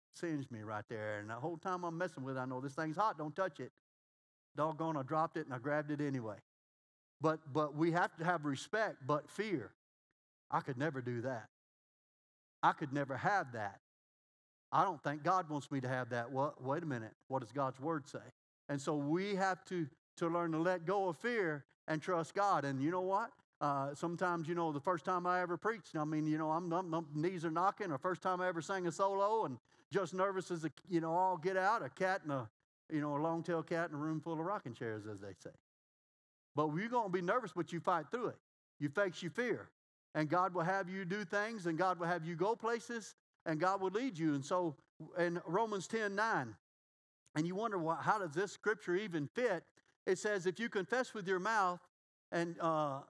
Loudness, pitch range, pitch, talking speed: -38 LUFS, 145-185 Hz, 165 Hz, 230 wpm